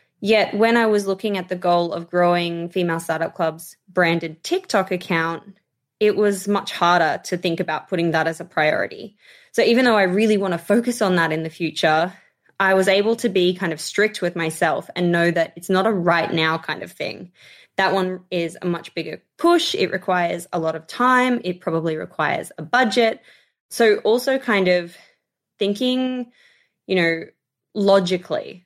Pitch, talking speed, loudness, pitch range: 185 Hz, 185 wpm, -20 LUFS, 170-210 Hz